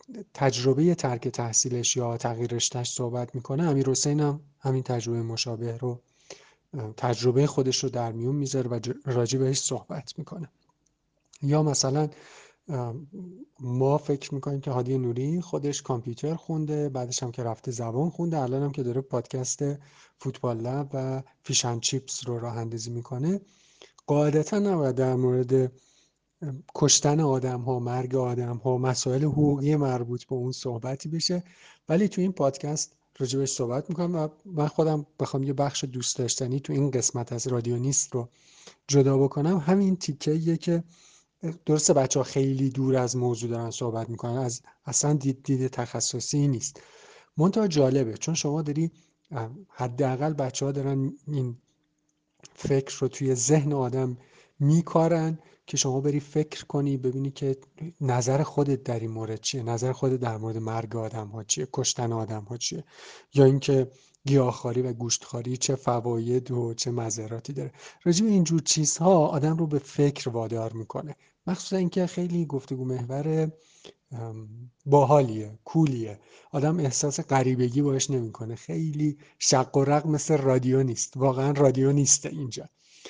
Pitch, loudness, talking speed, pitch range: 135 Hz, -26 LUFS, 145 wpm, 125-150 Hz